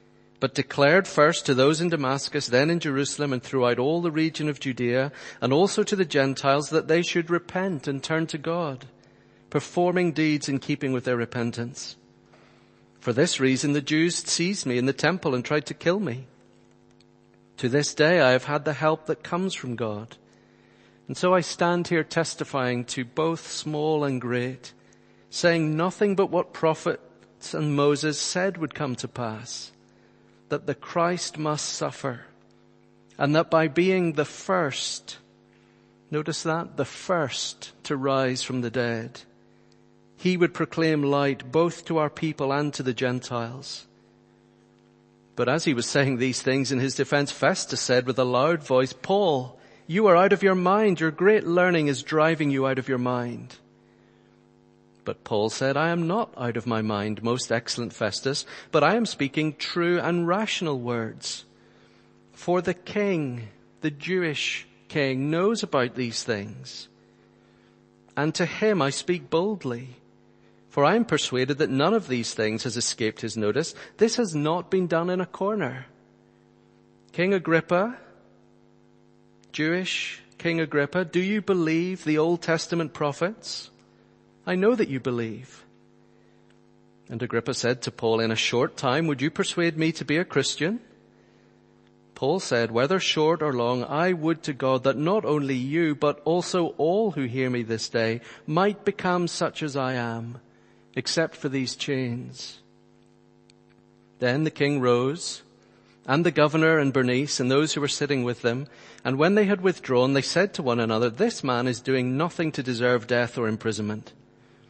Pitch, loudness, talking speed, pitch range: 135 Hz, -25 LUFS, 165 wpm, 120-165 Hz